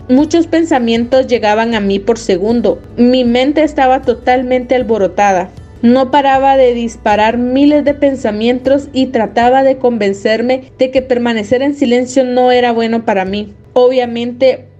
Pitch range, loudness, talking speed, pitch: 230-265 Hz, -11 LUFS, 140 wpm, 250 Hz